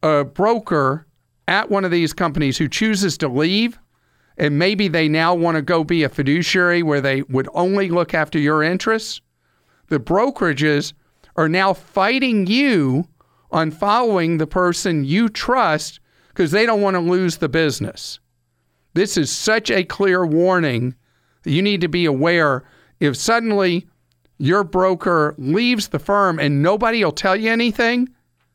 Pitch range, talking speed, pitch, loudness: 150-195 Hz, 155 wpm, 170 Hz, -18 LUFS